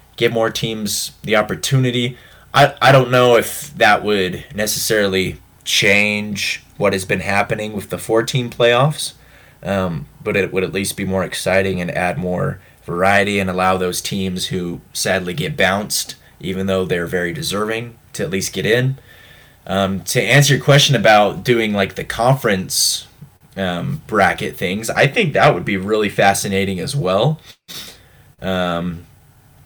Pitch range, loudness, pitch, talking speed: 95-125 Hz, -17 LUFS, 105 Hz, 155 wpm